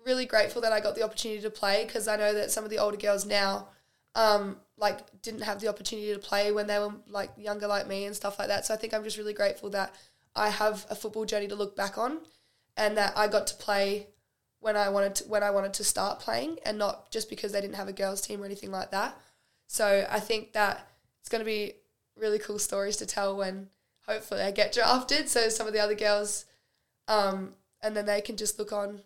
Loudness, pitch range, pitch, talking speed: -30 LUFS, 200-215 Hz, 210 Hz, 240 wpm